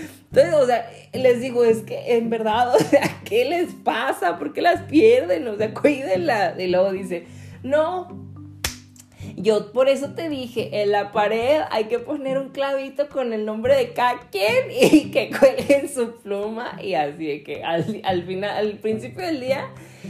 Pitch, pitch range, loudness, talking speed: 240 Hz, 200-280 Hz, -21 LUFS, 175 wpm